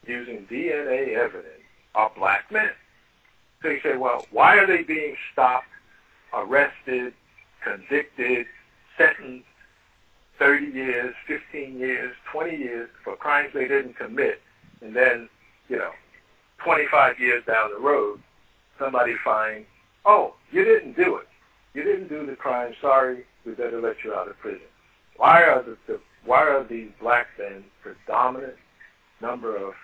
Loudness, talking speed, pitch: -22 LUFS, 140 wpm, 140 Hz